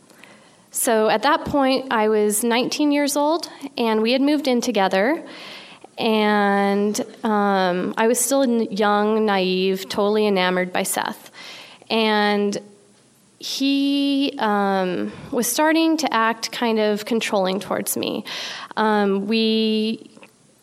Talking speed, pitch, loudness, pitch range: 115 wpm, 220 Hz, -20 LUFS, 205-260 Hz